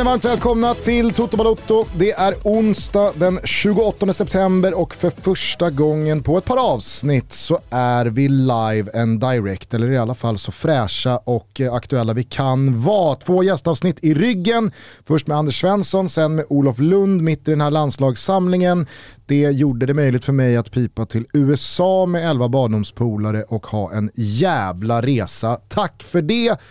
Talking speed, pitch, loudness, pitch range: 160 wpm, 145 Hz, -18 LUFS, 120-185 Hz